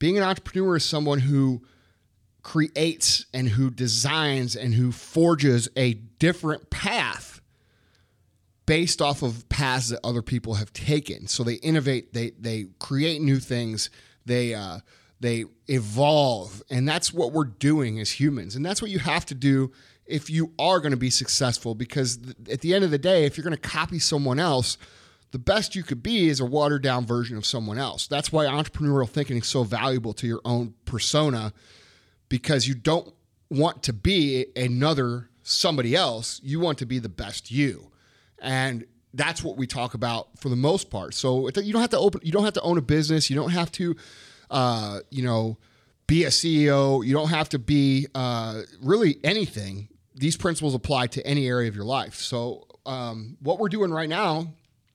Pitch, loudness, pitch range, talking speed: 130 Hz, -24 LUFS, 120-150 Hz, 185 wpm